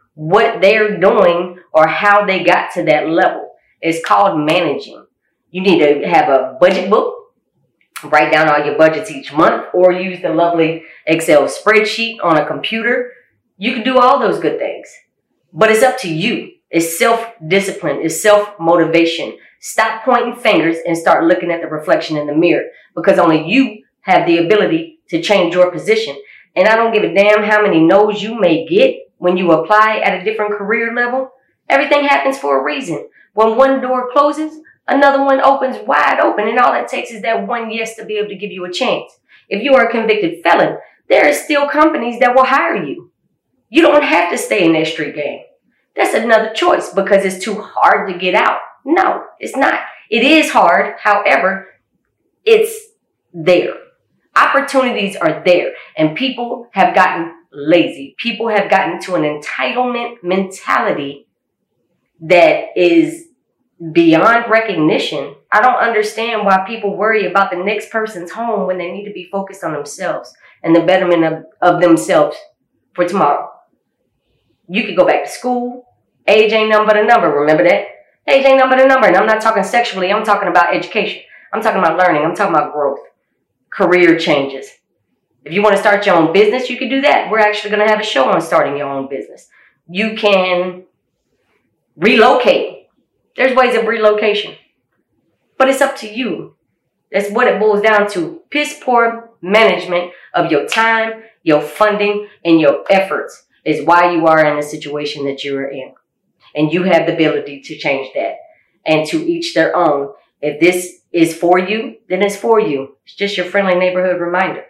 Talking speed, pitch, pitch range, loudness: 180 wpm, 205 Hz, 170-240 Hz, -13 LUFS